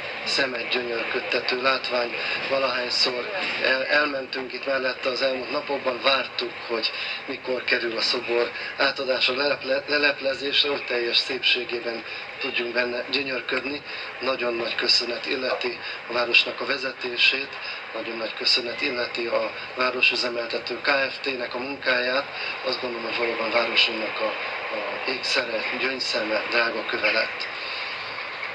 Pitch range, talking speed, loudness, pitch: 120-135 Hz, 110 wpm, -24 LUFS, 130 Hz